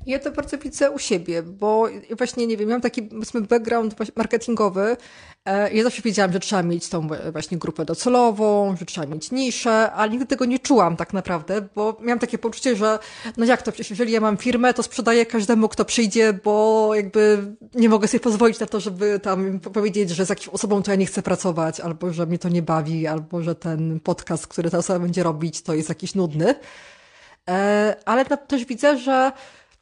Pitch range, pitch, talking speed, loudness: 185-235 Hz, 215 Hz, 195 wpm, -21 LUFS